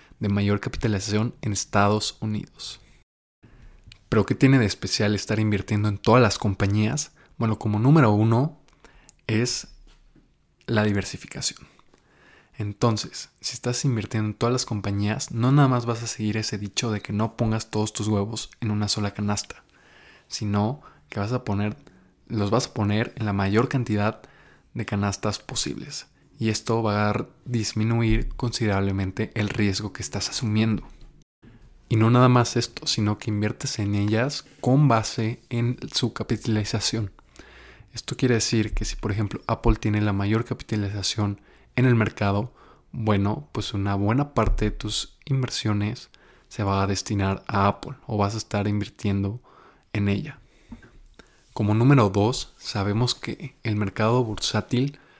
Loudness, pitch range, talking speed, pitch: -24 LUFS, 105-120 Hz, 150 wpm, 110 Hz